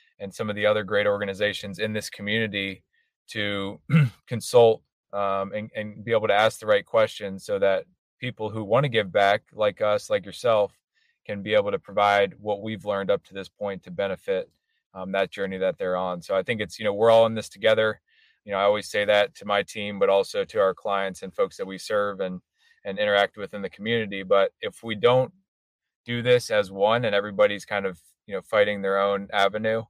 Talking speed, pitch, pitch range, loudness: 220 wpm, 105 Hz, 100-125 Hz, -24 LUFS